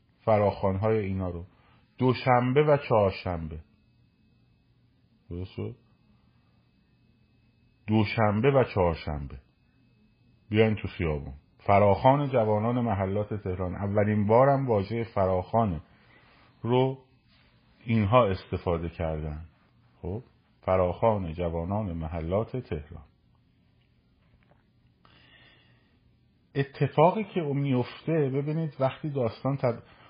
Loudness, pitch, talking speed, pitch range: -27 LUFS, 110 Hz, 75 wpm, 95-125 Hz